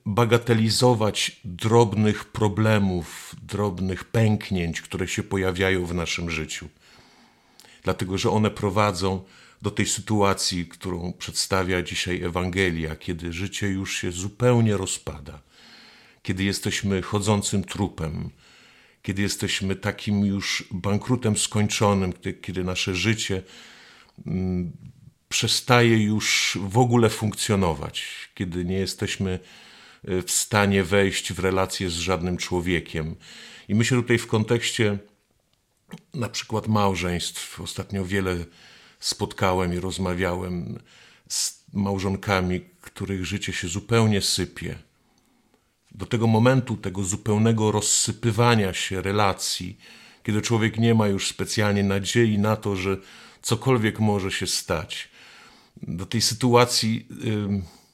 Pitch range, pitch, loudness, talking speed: 95-110 Hz, 100 Hz, -24 LUFS, 110 wpm